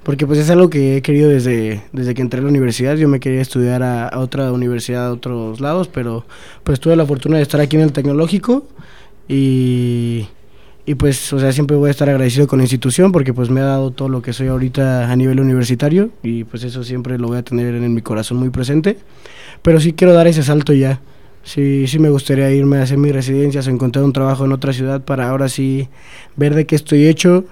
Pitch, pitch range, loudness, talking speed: 135 Hz, 125-145 Hz, -15 LUFS, 235 wpm